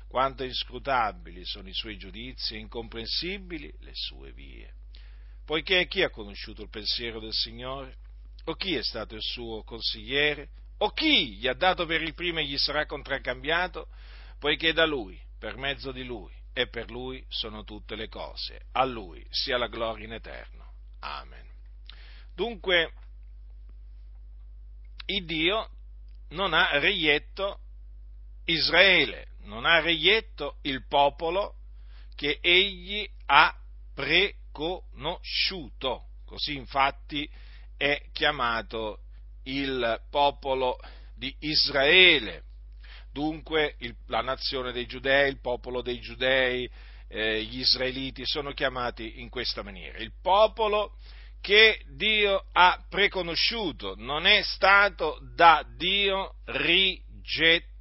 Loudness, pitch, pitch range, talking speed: -25 LUFS, 125 Hz, 95-155 Hz, 120 wpm